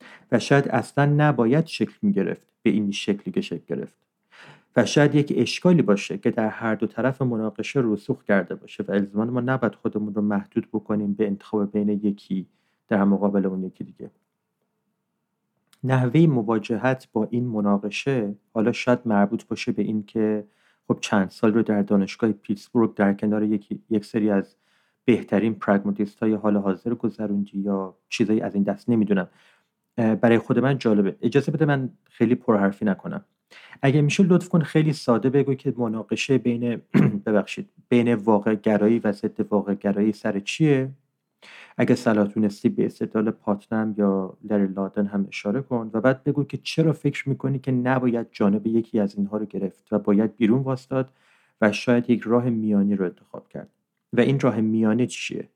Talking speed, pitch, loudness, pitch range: 165 wpm, 110 Hz, -23 LUFS, 105-130 Hz